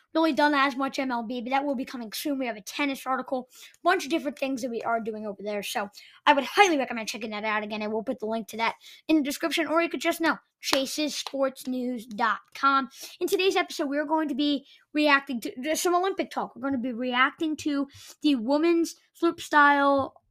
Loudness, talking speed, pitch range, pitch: -26 LUFS, 215 wpm, 250-315 Hz, 275 Hz